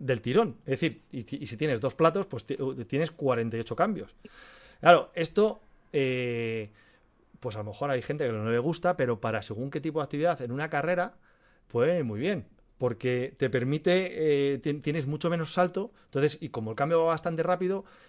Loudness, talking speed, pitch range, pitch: -29 LUFS, 195 wpm, 125-170 Hz, 145 Hz